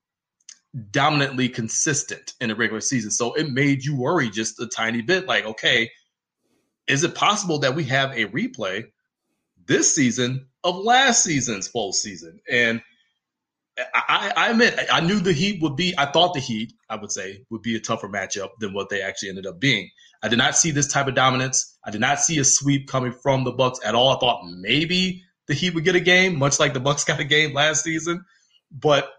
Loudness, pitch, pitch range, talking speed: -21 LUFS, 140 Hz, 120-160 Hz, 205 wpm